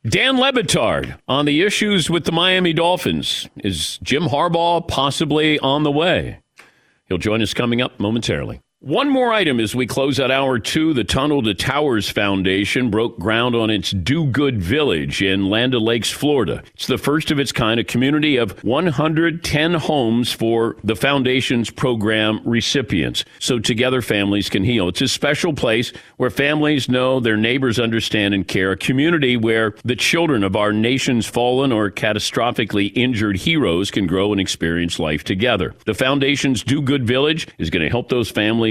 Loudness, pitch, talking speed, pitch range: -18 LUFS, 125 Hz, 170 wpm, 105-140 Hz